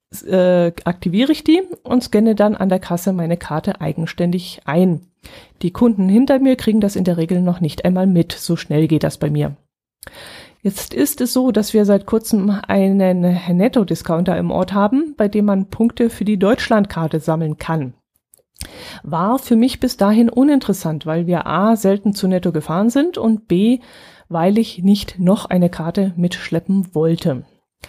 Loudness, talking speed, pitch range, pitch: -17 LUFS, 170 wpm, 175-225 Hz, 195 Hz